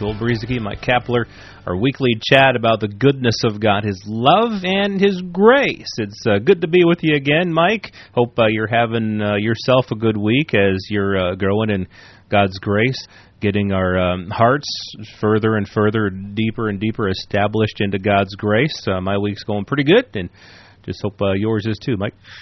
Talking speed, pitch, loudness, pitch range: 185 wpm, 110 Hz, -18 LUFS, 100-125 Hz